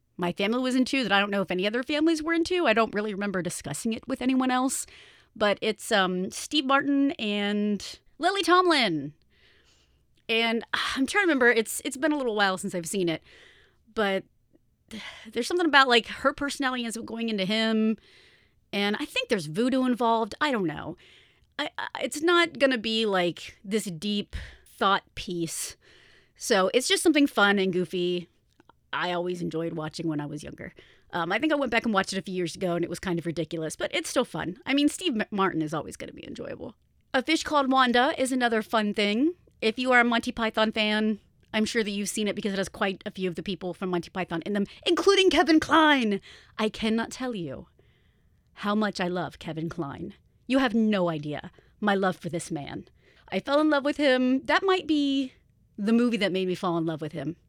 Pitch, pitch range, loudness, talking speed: 220 Hz, 185-265 Hz, -26 LUFS, 210 wpm